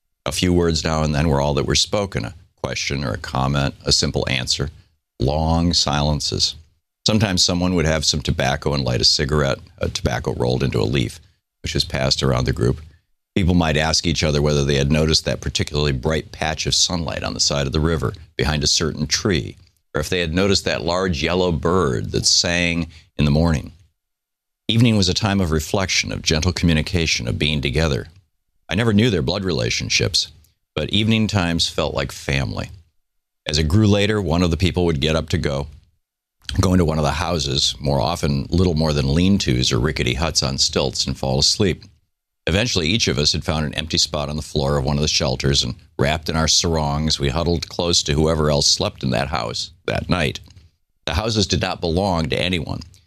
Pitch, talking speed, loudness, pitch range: 80 Hz, 205 wpm, -19 LUFS, 75-90 Hz